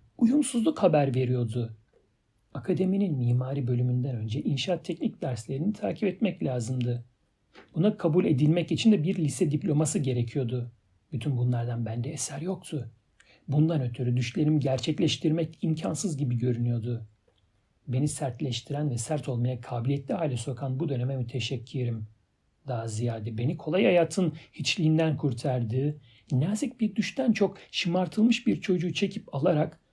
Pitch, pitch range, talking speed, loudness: 140 Hz, 125-175 Hz, 120 wpm, -28 LUFS